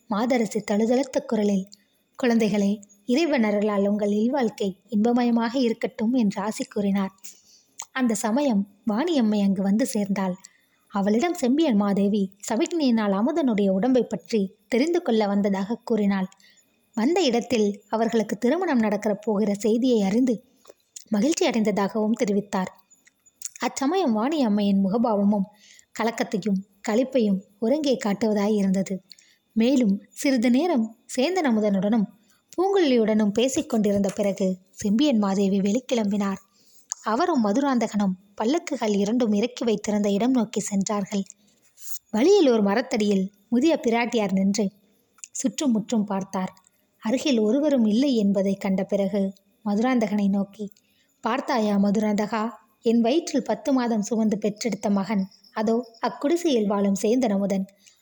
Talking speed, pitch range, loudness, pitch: 100 wpm, 205-245 Hz, -24 LUFS, 220 Hz